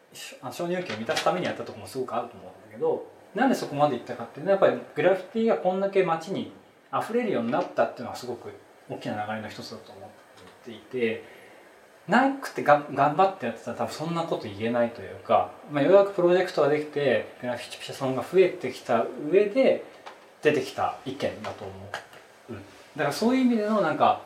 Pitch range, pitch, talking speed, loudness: 120-190 Hz, 145 Hz, 460 characters per minute, -26 LUFS